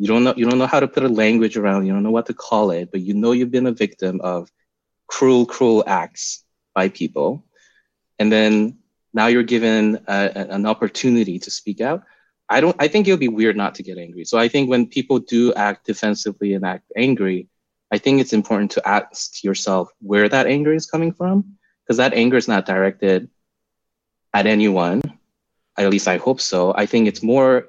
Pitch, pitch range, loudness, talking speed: 110 Hz, 100-125 Hz, -18 LUFS, 210 wpm